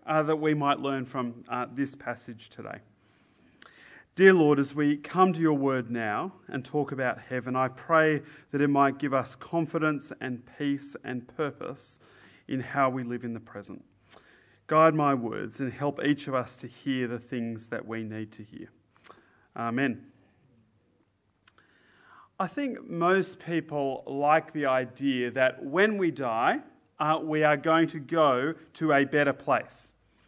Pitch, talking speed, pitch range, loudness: 140 Hz, 160 wpm, 125-155 Hz, -28 LUFS